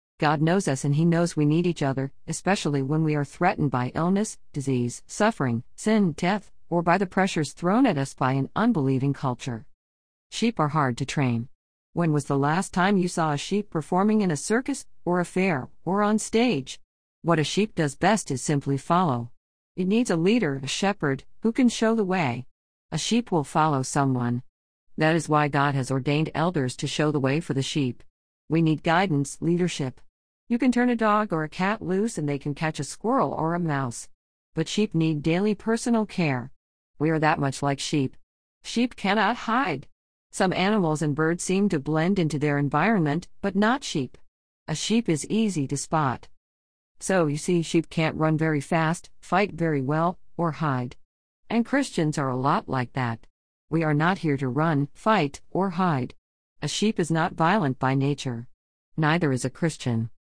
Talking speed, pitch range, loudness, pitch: 190 wpm, 135-185 Hz, -25 LUFS, 155 Hz